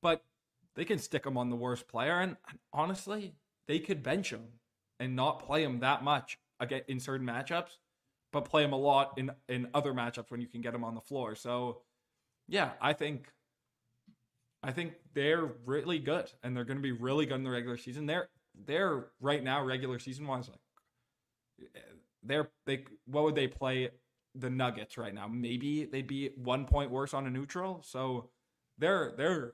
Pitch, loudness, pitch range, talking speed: 130 Hz, -35 LUFS, 125-145 Hz, 185 wpm